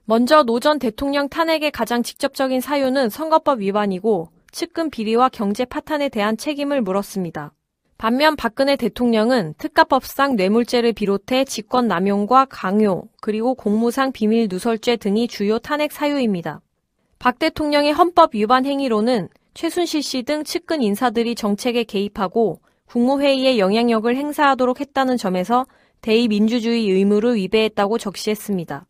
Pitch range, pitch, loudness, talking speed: 215-275 Hz, 240 Hz, -19 LUFS, 345 characters per minute